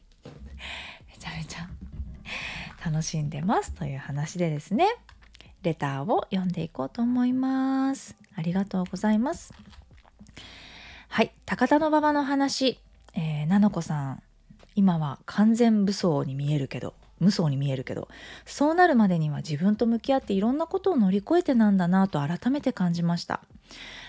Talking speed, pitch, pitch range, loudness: 335 characters per minute, 195 Hz, 155-245 Hz, -26 LUFS